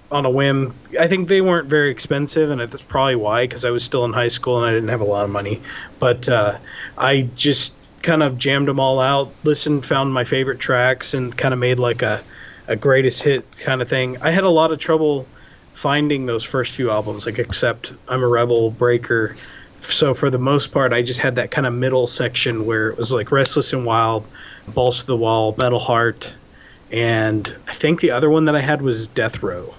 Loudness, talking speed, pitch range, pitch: -18 LUFS, 220 wpm, 120-140 Hz, 130 Hz